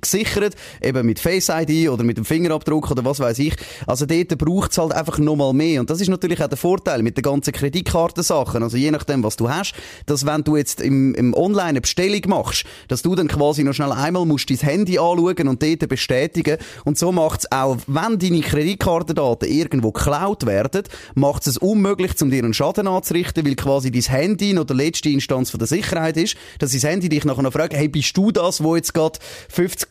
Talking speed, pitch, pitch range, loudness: 215 wpm, 150 Hz, 135-175 Hz, -19 LUFS